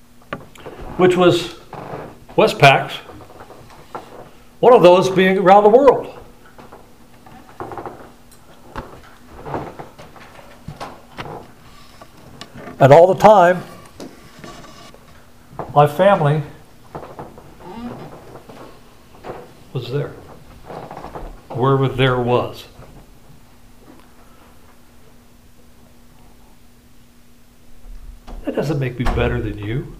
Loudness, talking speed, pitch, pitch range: -14 LUFS, 55 wpm, 145 Hz, 125-180 Hz